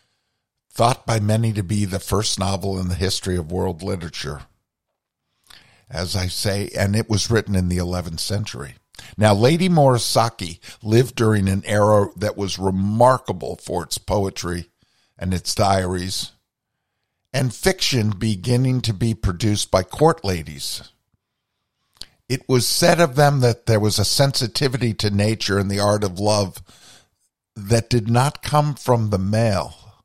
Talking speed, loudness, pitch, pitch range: 150 wpm, -20 LUFS, 105 Hz, 95-120 Hz